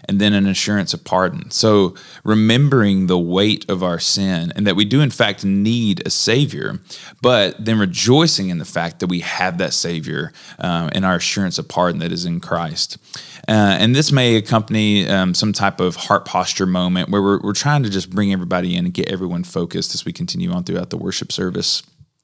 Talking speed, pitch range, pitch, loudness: 205 wpm, 90-110 Hz, 100 Hz, -17 LUFS